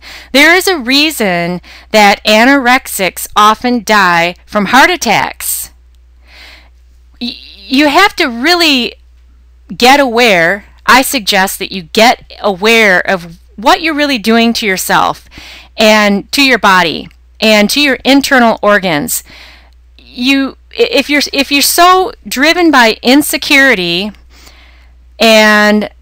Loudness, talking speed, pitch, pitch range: -8 LUFS, 115 wpm, 215 Hz, 175-270 Hz